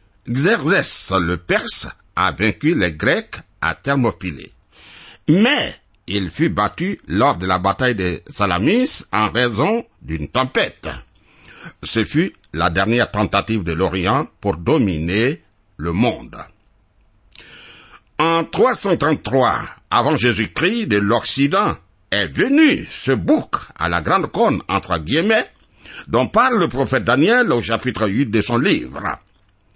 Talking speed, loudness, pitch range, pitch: 125 wpm, -18 LUFS, 95-125 Hz, 105 Hz